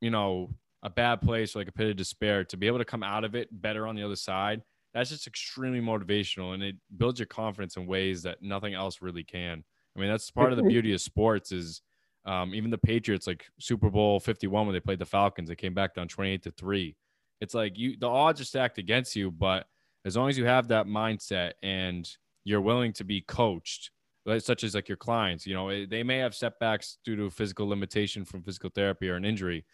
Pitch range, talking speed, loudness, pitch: 95-115 Hz, 235 wpm, -30 LUFS, 105 Hz